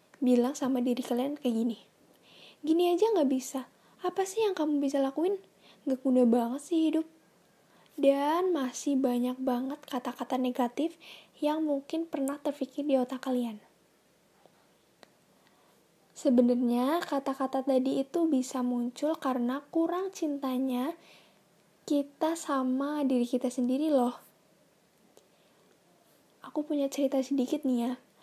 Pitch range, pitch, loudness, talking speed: 255-300 Hz, 270 Hz, -30 LUFS, 115 wpm